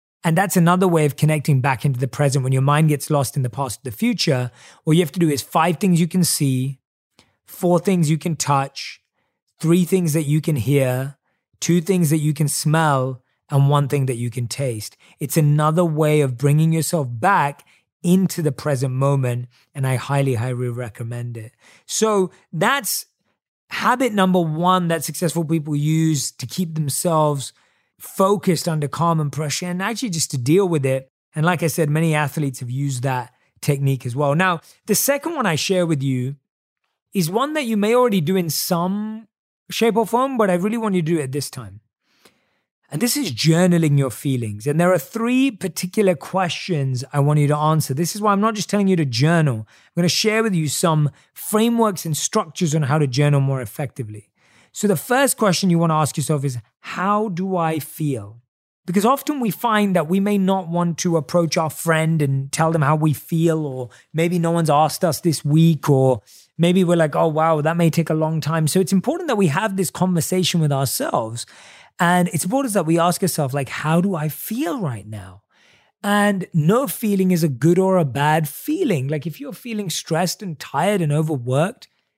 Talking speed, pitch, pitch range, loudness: 200 wpm, 160 Hz, 140-185 Hz, -19 LUFS